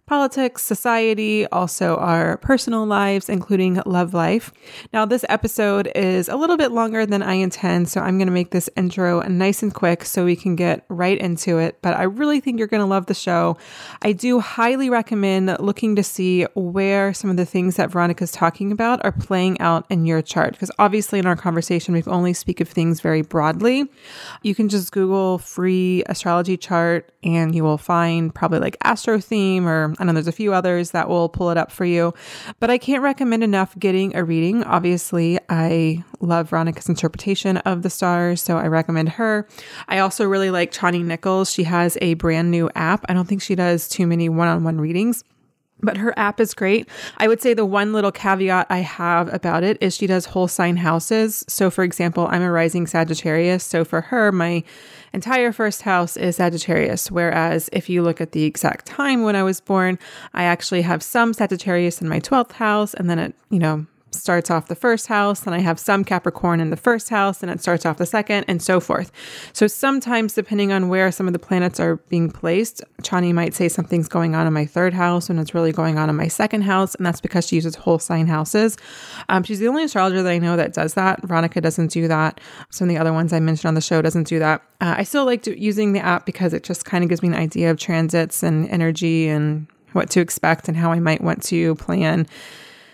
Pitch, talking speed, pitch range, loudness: 180 Hz, 220 wpm, 170-205 Hz, -19 LUFS